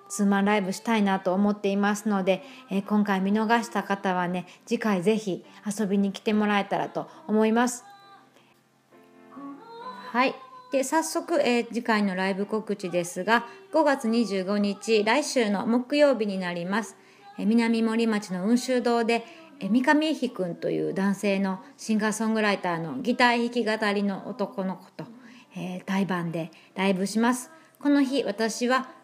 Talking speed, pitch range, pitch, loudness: 295 characters per minute, 195-245 Hz, 220 Hz, -26 LUFS